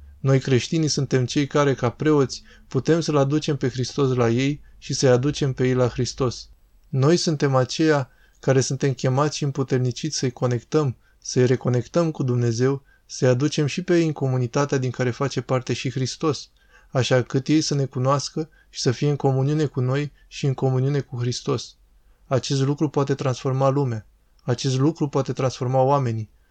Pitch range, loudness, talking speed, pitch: 125-145 Hz, -22 LUFS, 170 wpm, 135 Hz